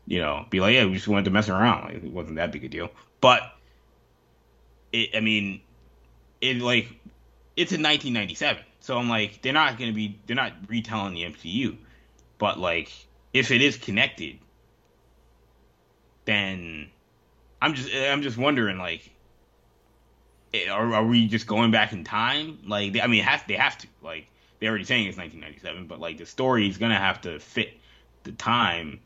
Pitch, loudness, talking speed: 105 Hz, -24 LUFS, 175 wpm